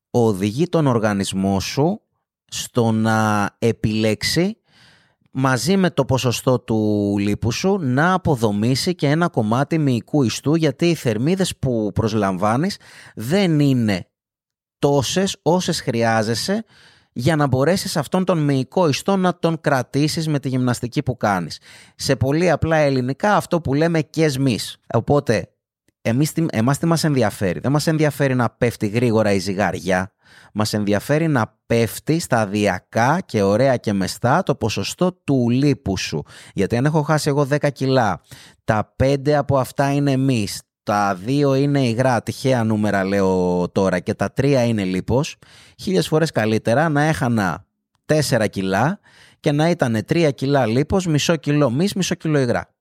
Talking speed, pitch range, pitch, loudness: 145 wpm, 110-150 Hz, 130 Hz, -19 LUFS